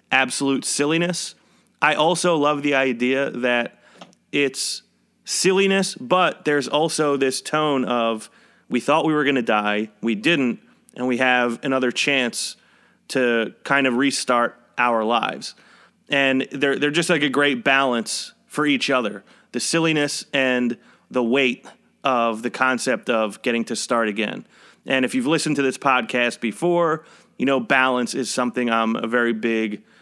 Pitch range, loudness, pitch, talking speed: 120-145 Hz, -21 LUFS, 130 Hz, 155 wpm